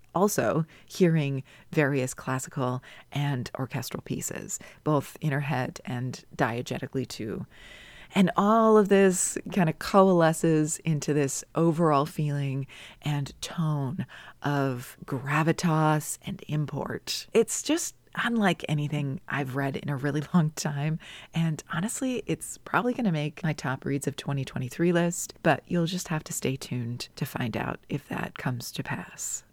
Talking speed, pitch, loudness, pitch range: 140 wpm, 150 Hz, -28 LUFS, 135-170 Hz